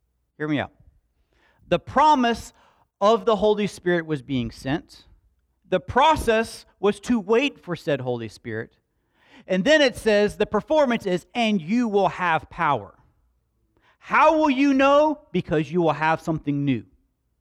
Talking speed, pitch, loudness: 150 wpm, 185 Hz, -22 LUFS